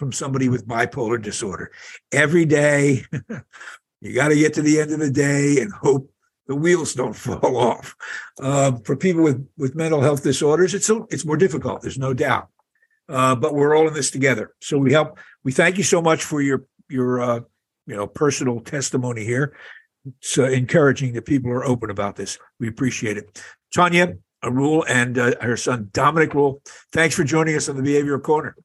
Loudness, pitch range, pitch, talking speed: -20 LUFS, 125-155 Hz, 140 Hz, 190 wpm